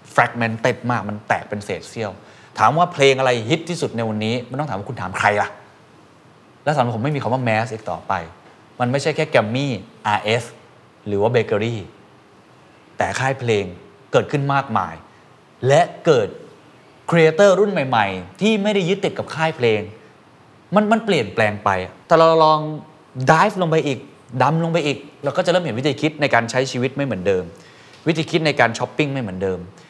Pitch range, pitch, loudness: 115-155 Hz, 130 Hz, -19 LUFS